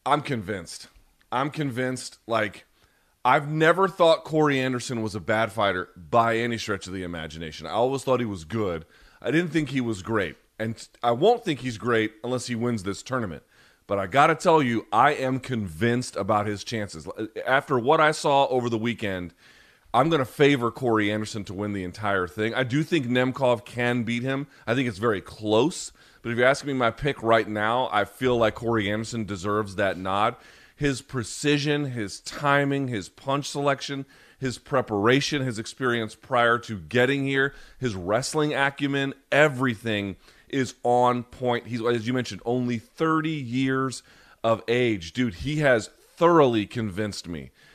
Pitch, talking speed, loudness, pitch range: 120 Hz, 175 wpm, -25 LUFS, 110-135 Hz